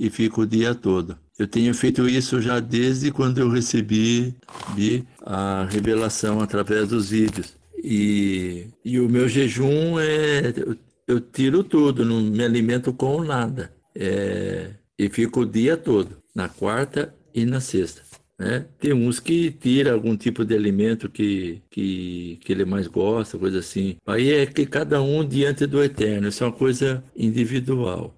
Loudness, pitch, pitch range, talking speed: -22 LUFS, 120 Hz, 105-130 Hz, 160 wpm